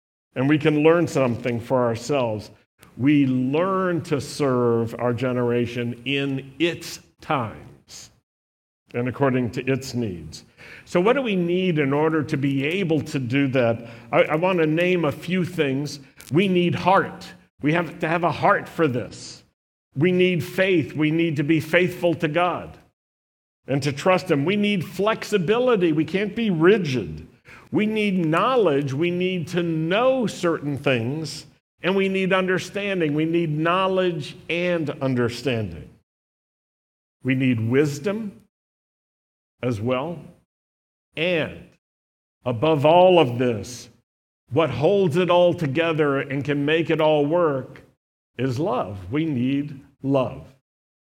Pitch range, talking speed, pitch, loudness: 125-175 Hz, 140 wpm, 150 Hz, -22 LUFS